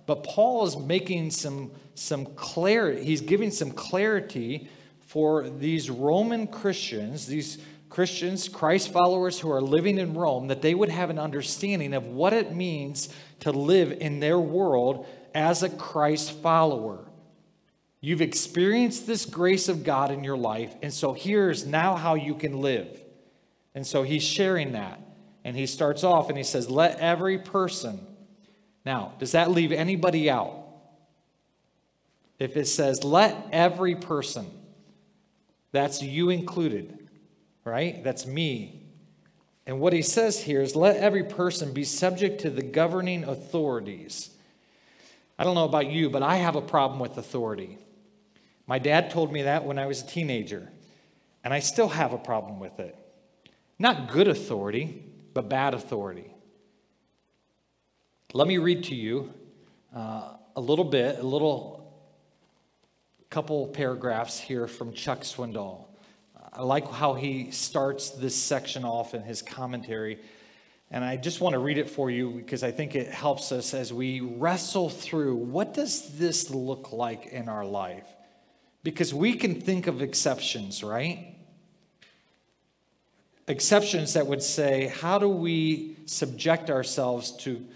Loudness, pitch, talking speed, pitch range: -27 LUFS, 155 Hz, 150 wpm, 135-180 Hz